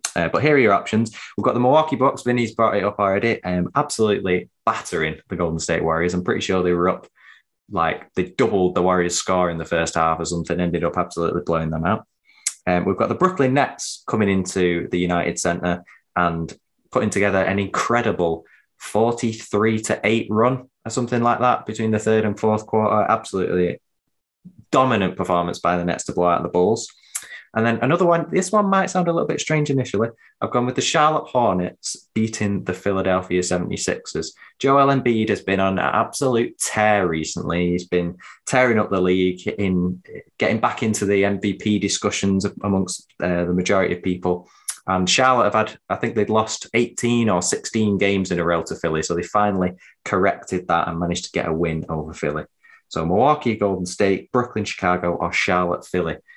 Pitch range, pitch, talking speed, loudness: 90-110 Hz, 95 Hz, 190 wpm, -21 LUFS